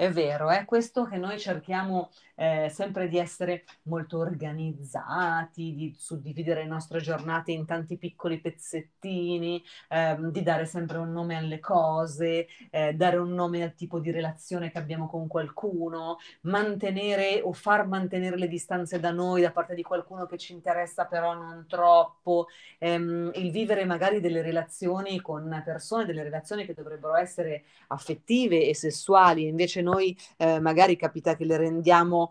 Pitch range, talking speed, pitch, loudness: 160-180 Hz, 155 wpm, 170 Hz, -28 LUFS